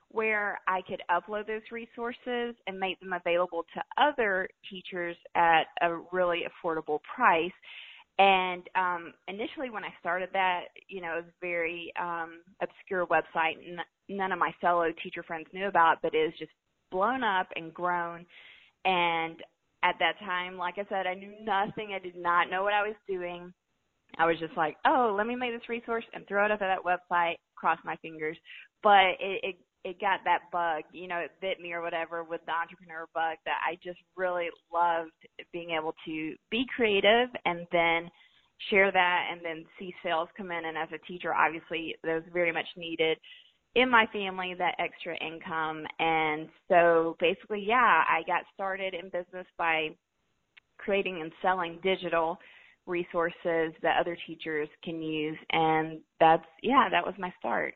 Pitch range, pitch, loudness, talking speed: 165-190 Hz, 175 Hz, -29 LUFS, 175 wpm